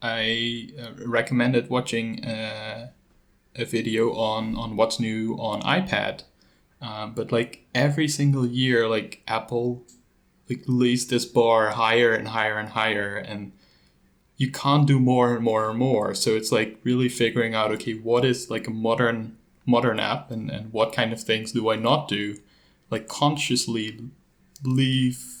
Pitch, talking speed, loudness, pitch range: 115 Hz, 155 wpm, -24 LUFS, 110-125 Hz